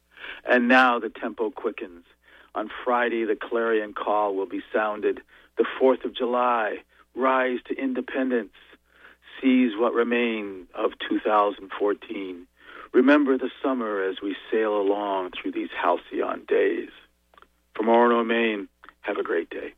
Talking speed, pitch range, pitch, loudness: 130 wpm, 105-130 Hz, 120 Hz, -24 LUFS